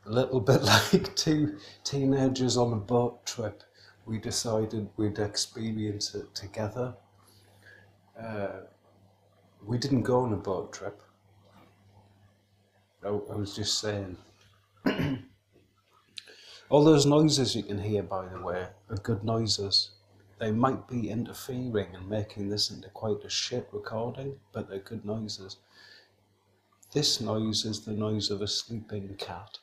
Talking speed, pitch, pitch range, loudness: 130 wpm, 105 Hz, 100-115 Hz, -29 LUFS